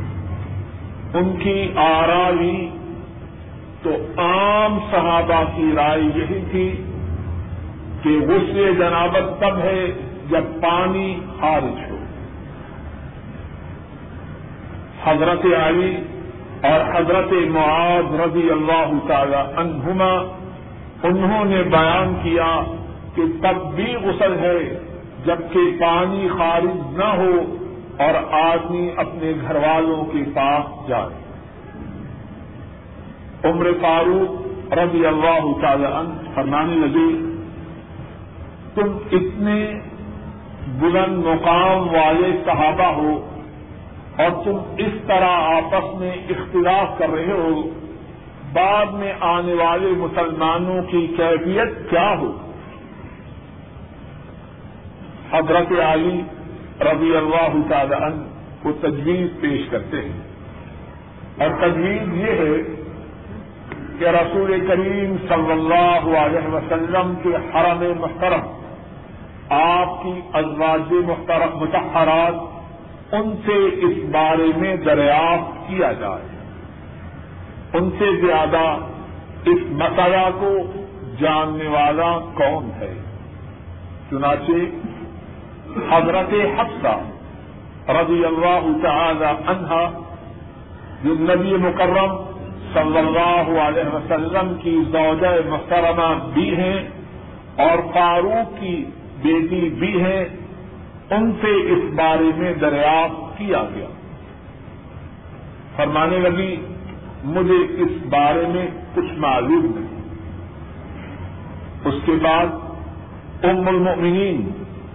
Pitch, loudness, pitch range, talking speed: 170 Hz, -18 LUFS, 155-180 Hz, 95 wpm